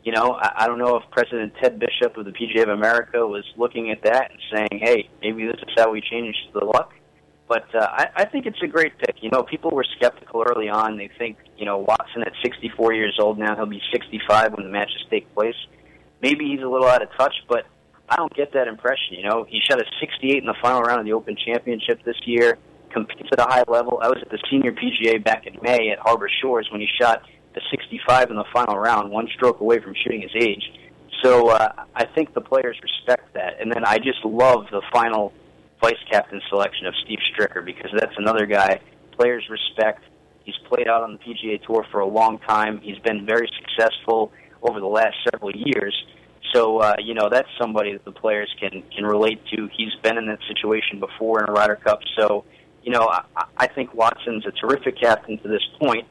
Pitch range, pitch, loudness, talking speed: 105-120 Hz, 110 Hz, -21 LUFS, 220 wpm